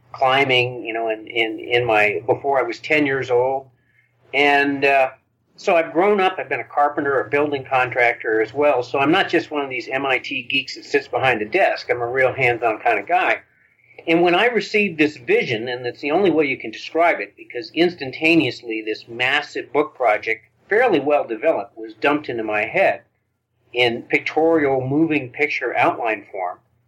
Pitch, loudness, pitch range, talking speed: 130 Hz, -19 LUFS, 120-150 Hz, 190 wpm